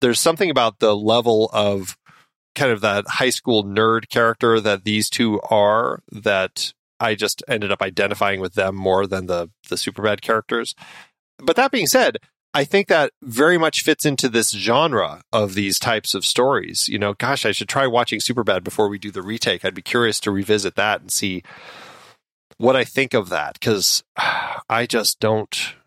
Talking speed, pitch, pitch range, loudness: 185 wpm, 110 Hz, 100-120 Hz, -19 LUFS